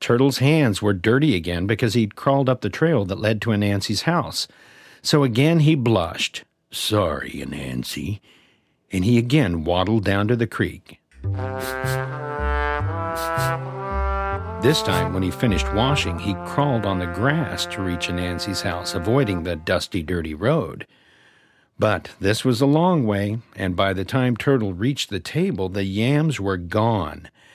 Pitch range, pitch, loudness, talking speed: 90-130 Hz, 100 Hz, -22 LUFS, 150 wpm